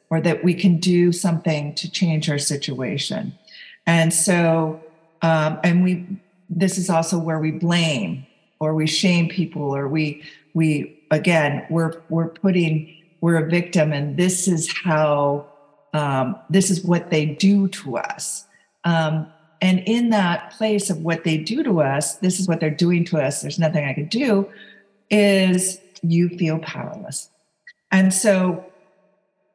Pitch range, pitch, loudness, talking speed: 155-185 Hz, 170 Hz, -20 LUFS, 155 wpm